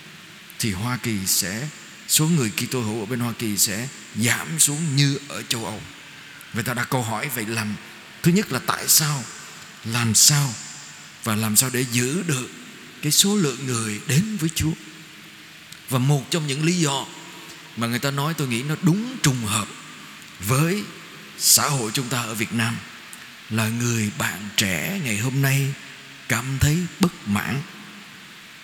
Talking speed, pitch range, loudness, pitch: 170 wpm, 115-155 Hz, -22 LUFS, 130 Hz